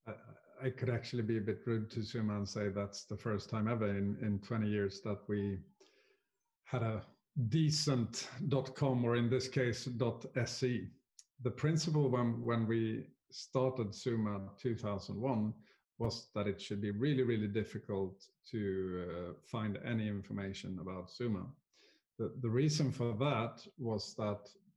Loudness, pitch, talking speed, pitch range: -38 LUFS, 115 Hz, 150 wpm, 105-130 Hz